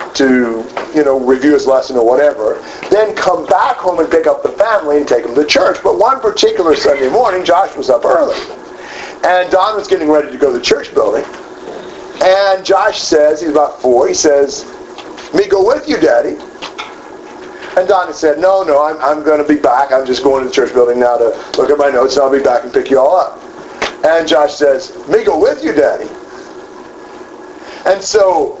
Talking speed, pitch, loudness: 205 wpm, 180 Hz, -11 LUFS